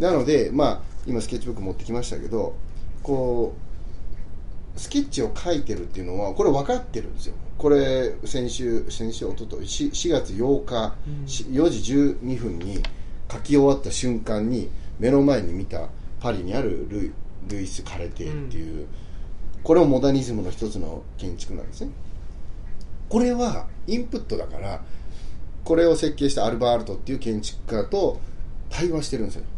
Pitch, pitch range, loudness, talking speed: 110 Hz, 90-135 Hz, -25 LUFS, 320 characters per minute